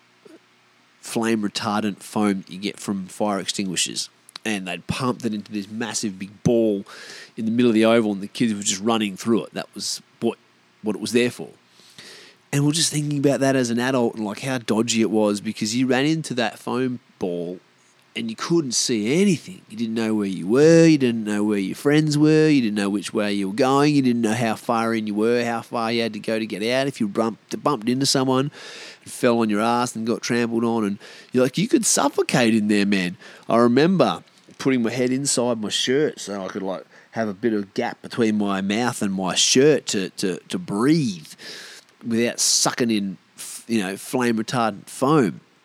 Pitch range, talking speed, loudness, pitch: 105-125 Hz, 215 wpm, -21 LUFS, 115 Hz